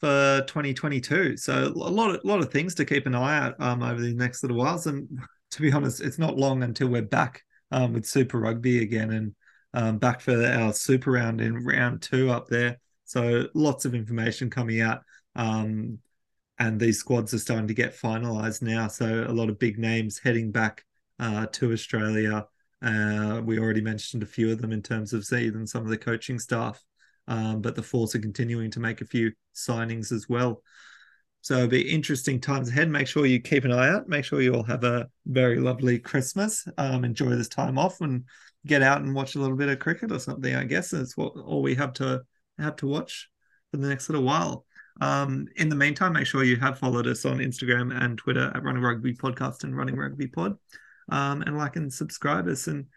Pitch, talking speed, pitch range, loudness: 125 Hz, 215 wpm, 115-140 Hz, -26 LUFS